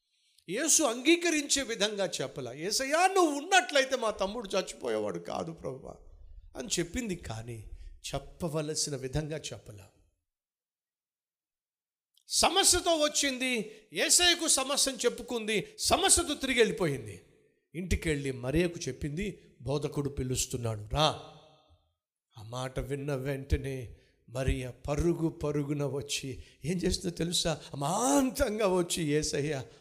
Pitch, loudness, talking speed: 155 Hz, -29 LUFS, 95 wpm